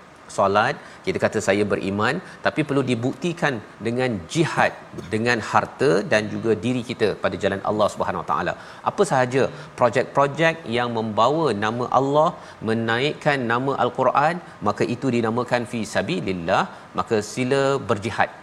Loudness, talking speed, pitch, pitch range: -22 LUFS, 130 wpm, 120 Hz, 110-135 Hz